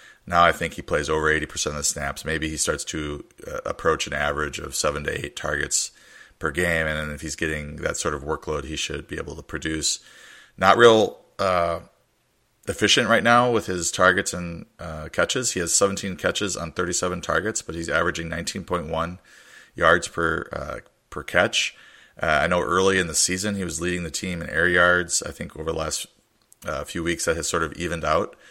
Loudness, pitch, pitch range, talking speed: -23 LUFS, 85 Hz, 80-90 Hz, 210 wpm